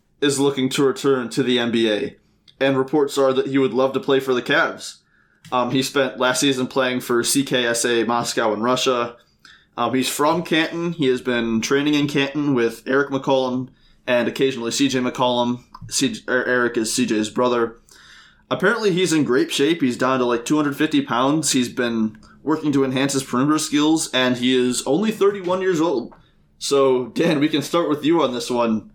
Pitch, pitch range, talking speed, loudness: 130 Hz, 125-145 Hz, 180 wpm, -20 LUFS